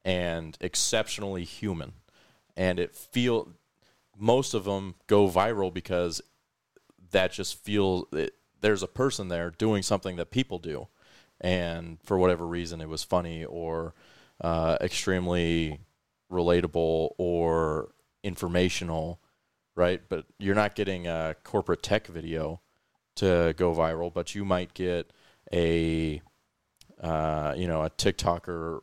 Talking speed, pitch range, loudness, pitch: 125 wpm, 80-95 Hz, -29 LUFS, 90 Hz